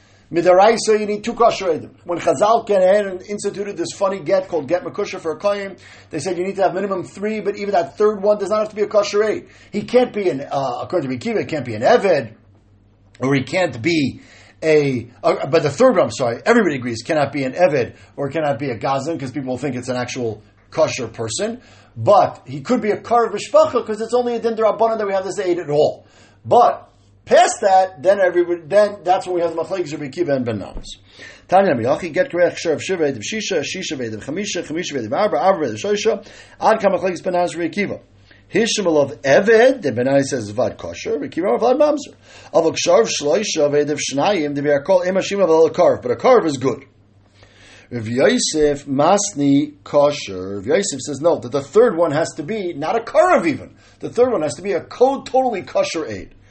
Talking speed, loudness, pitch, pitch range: 200 wpm, -18 LUFS, 175 Hz, 140-205 Hz